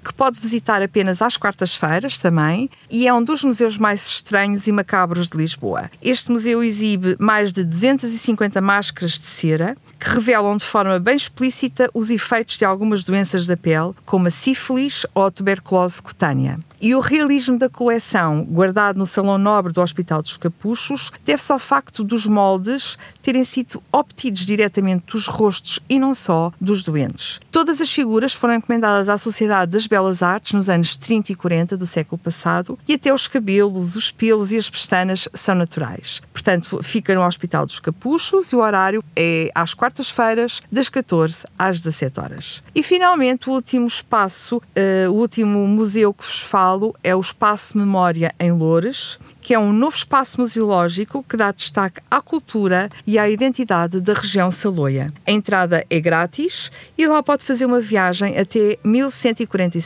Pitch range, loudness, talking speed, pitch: 180-240 Hz, -18 LUFS, 170 wpm, 205 Hz